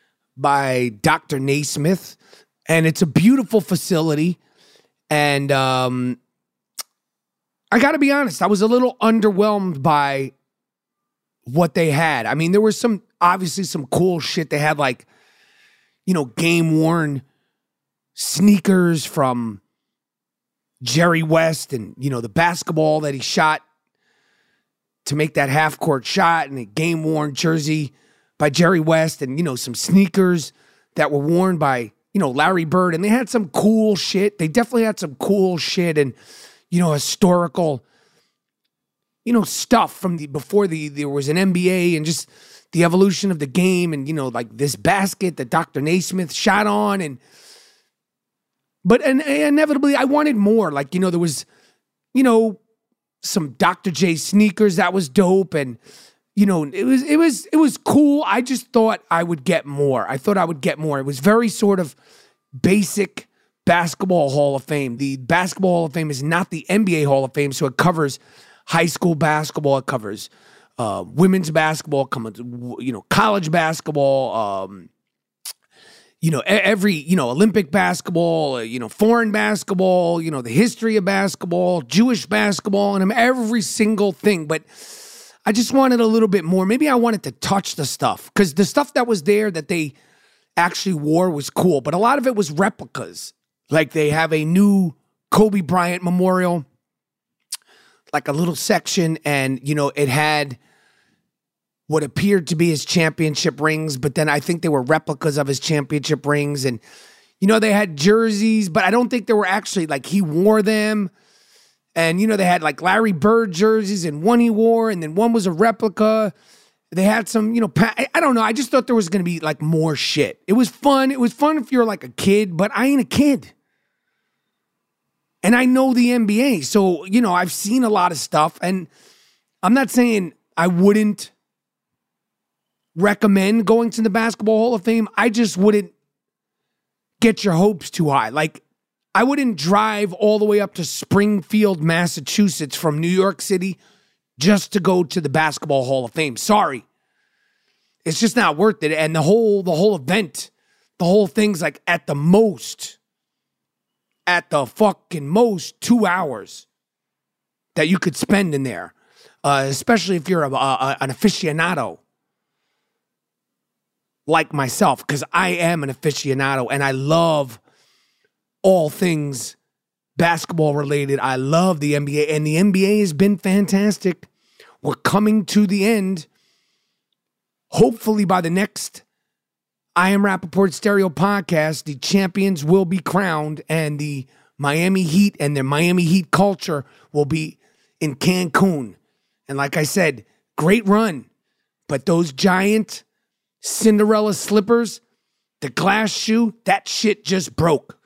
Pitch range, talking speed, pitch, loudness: 155-210 Hz, 165 wpm, 180 Hz, -18 LUFS